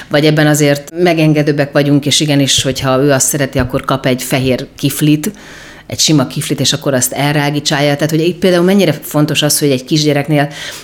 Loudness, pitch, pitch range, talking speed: -12 LUFS, 145 Hz, 135-150 Hz, 185 wpm